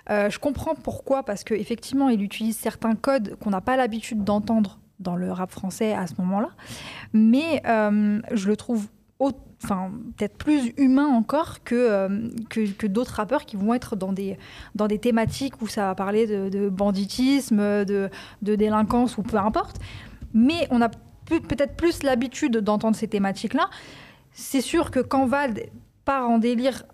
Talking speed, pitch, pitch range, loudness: 175 wpm, 225 Hz, 205-255 Hz, -24 LUFS